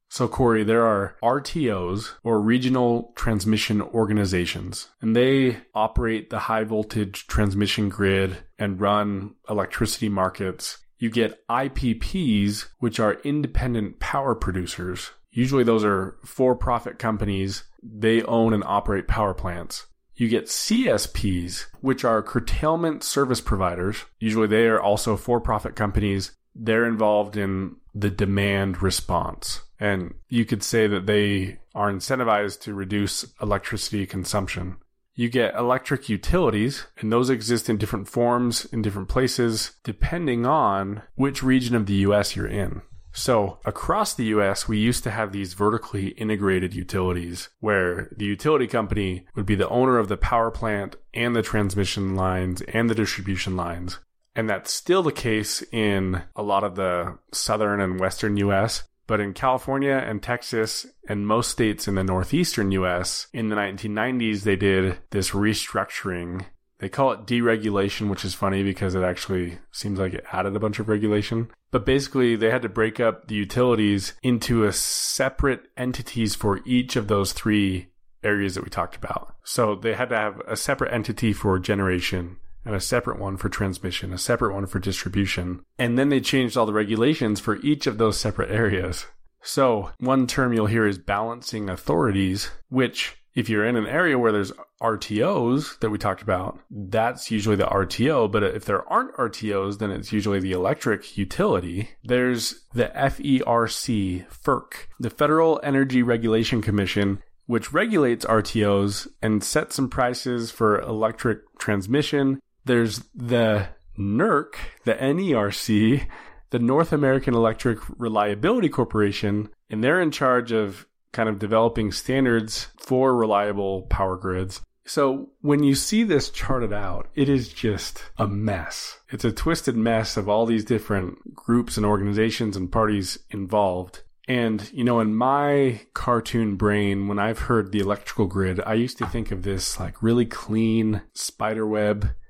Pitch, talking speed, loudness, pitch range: 110 Hz, 155 wpm, -24 LUFS, 100-120 Hz